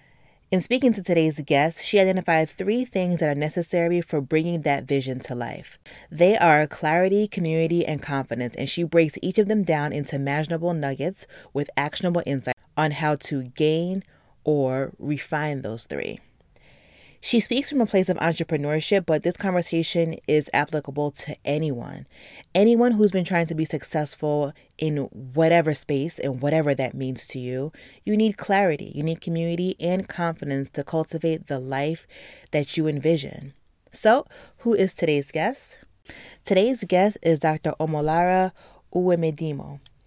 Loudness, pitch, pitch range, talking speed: -24 LUFS, 160 Hz, 145-180 Hz, 150 wpm